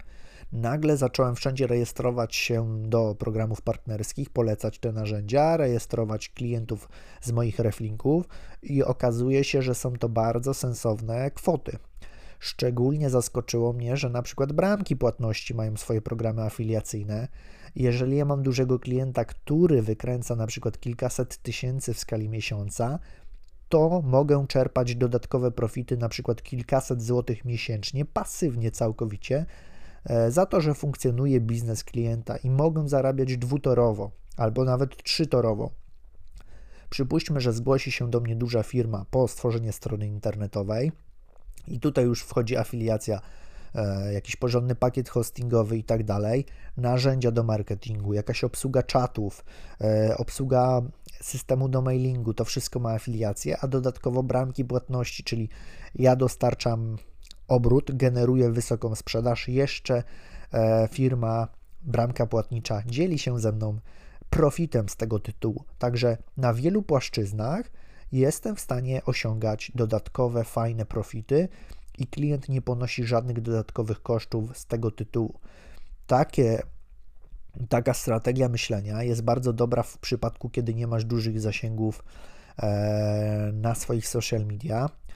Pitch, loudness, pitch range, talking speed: 120 Hz, -27 LUFS, 110-130 Hz, 125 wpm